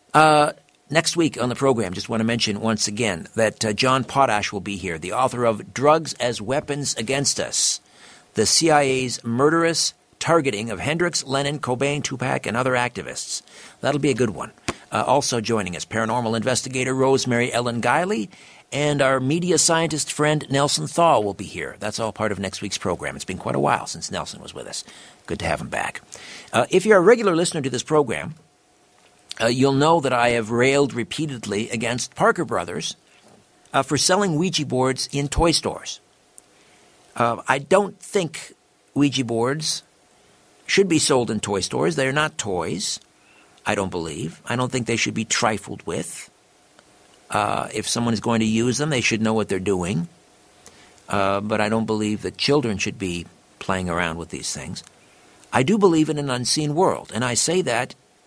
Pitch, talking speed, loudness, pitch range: 130 Hz, 185 wpm, -21 LUFS, 110-150 Hz